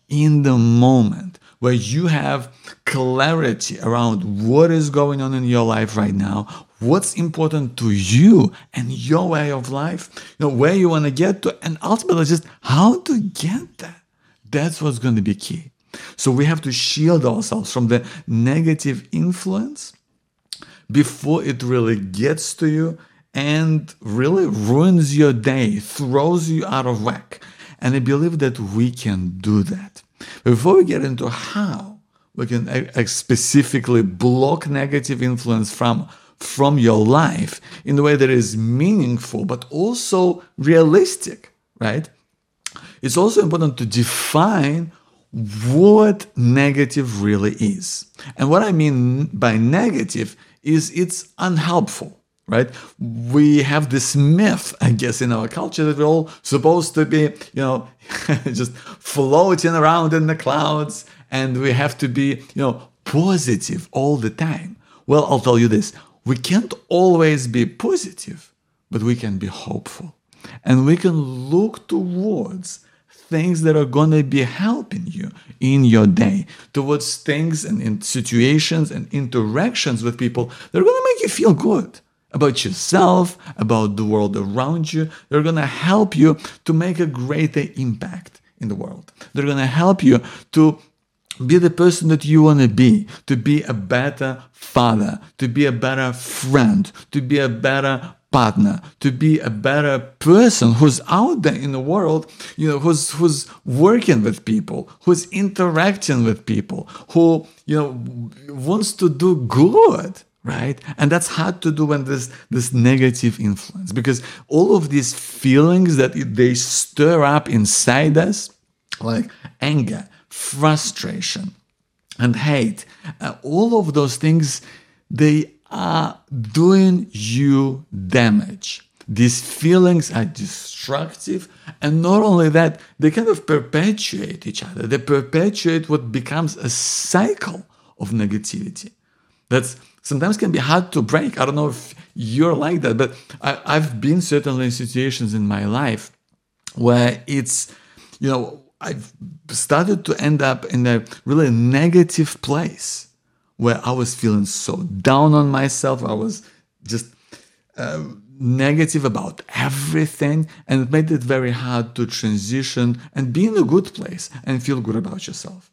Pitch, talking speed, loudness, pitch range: 145 Hz, 150 wpm, -18 LUFS, 125-170 Hz